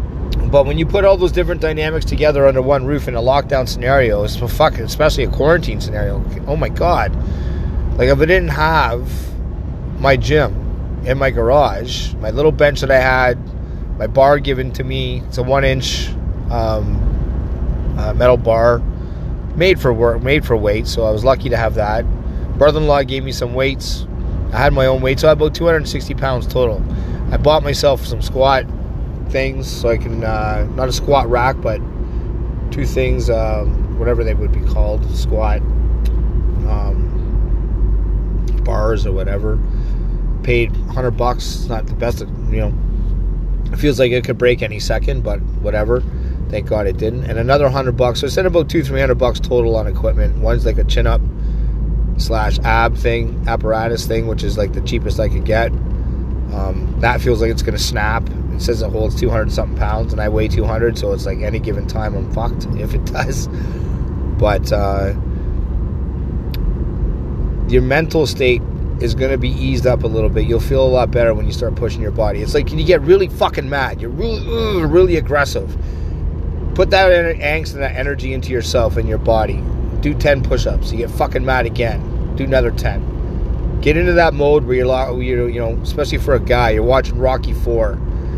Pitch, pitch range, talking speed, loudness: 110 Hz, 85-130 Hz, 185 wpm, -17 LUFS